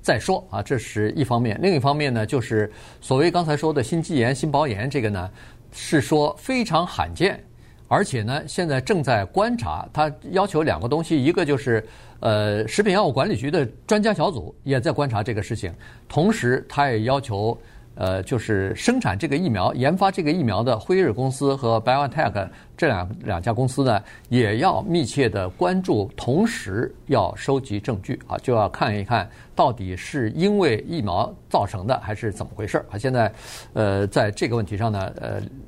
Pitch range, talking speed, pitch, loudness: 110-155 Hz, 285 characters per minute, 125 Hz, -22 LUFS